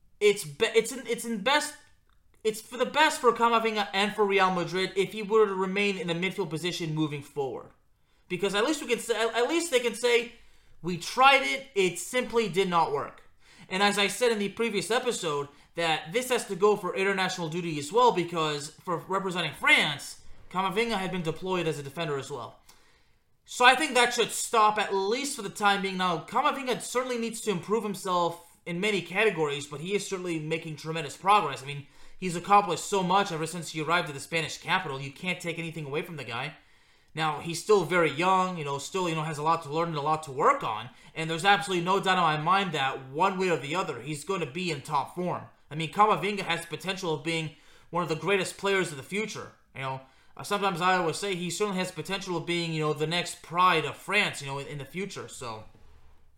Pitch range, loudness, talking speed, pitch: 160-210 Hz, -27 LUFS, 225 wpm, 185 Hz